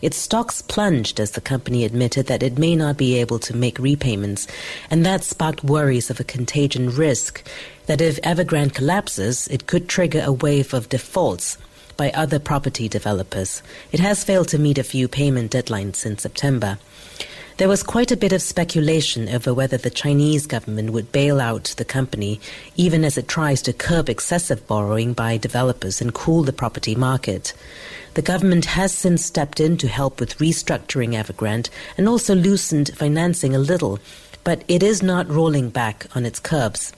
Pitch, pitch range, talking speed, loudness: 140 Hz, 120-165 Hz, 175 wpm, -20 LUFS